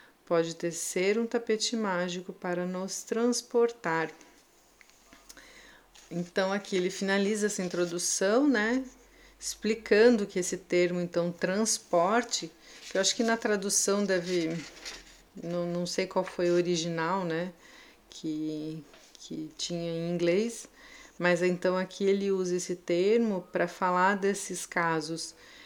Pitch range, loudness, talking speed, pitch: 175-205 Hz, -29 LUFS, 125 wpm, 185 Hz